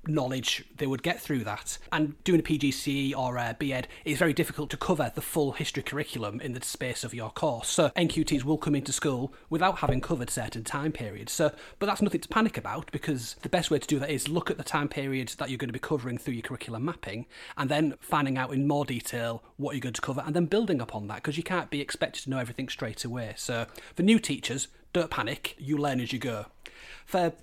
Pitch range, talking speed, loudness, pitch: 125-155 Hz, 240 wpm, -30 LUFS, 145 Hz